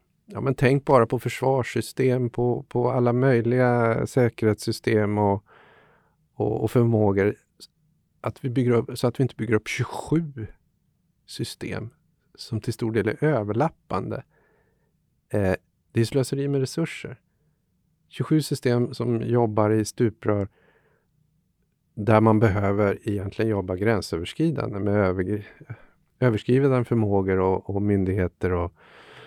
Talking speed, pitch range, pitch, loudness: 120 wpm, 105-130 Hz, 115 Hz, -24 LUFS